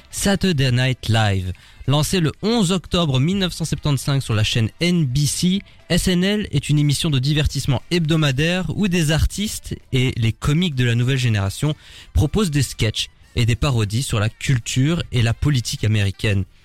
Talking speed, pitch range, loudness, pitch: 150 wpm, 115-165 Hz, -20 LUFS, 140 Hz